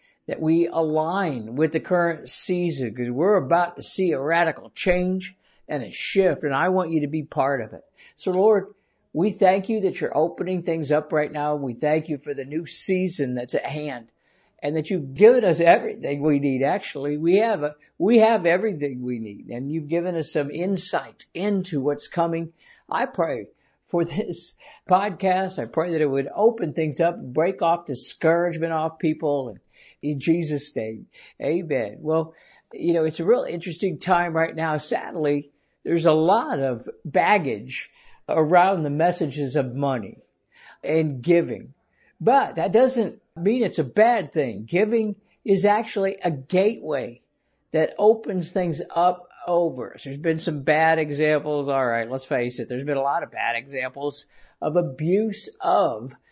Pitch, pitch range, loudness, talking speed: 165 Hz, 145-185 Hz, -23 LUFS, 175 wpm